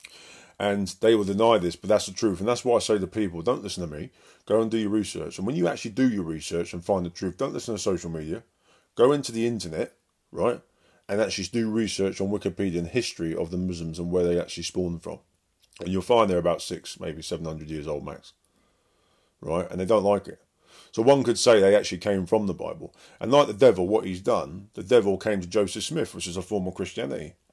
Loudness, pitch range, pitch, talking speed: -25 LUFS, 85-110 Hz, 95 Hz, 240 wpm